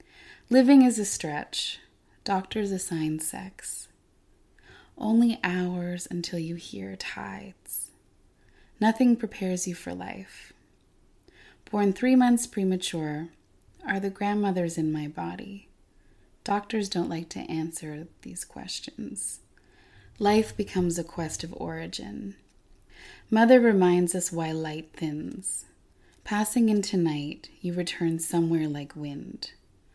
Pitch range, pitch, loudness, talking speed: 150-205 Hz, 175 Hz, -27 LUFS, 110 wpm